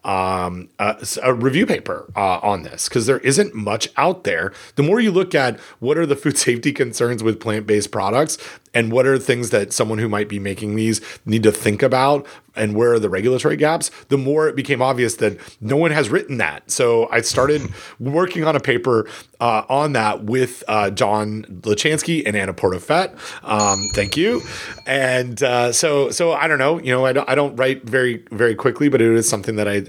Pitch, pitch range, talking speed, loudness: 120 Hz, 105-140 Hz, 210 wpm, -18 LUFS